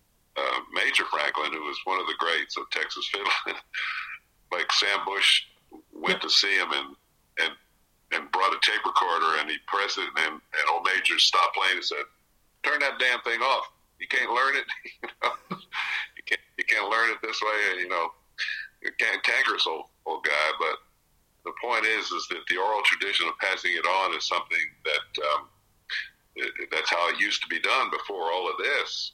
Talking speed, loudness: 195 wpm, -25 LUFS